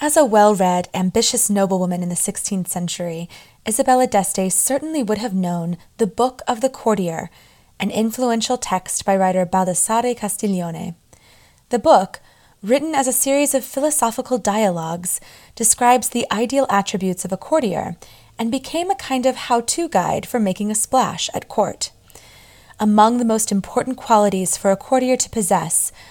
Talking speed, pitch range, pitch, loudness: 155 wpm, 185-255 Hz, 215 Hz, -18 LUFS